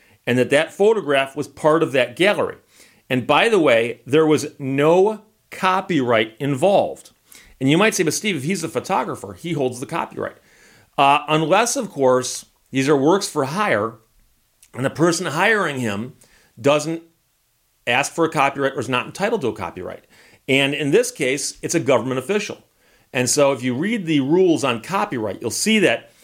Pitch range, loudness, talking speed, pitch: 130-180 Hz, -19 LUFS, 180 wpm, 145 Hz